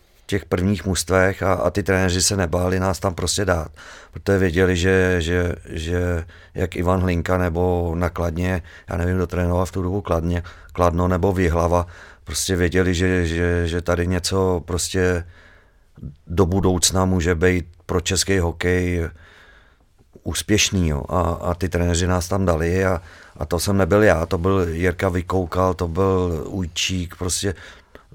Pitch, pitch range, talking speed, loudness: 90 Hz, 85-95 Hz, 150 wpm, -21 LUFS